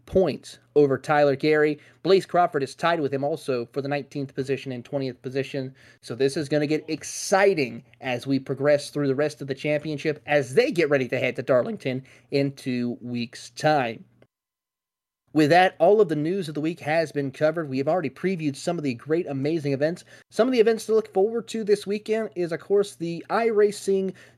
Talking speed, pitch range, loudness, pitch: 205 wpm, 135-175 Hz, -24 LUFS, 150 Hz